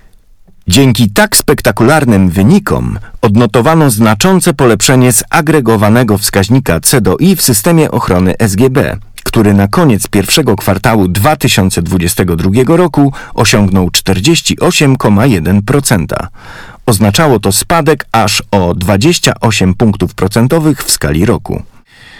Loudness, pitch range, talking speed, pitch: -9 LUFS, 100-145 Hz, 95 wpm, 115 Hz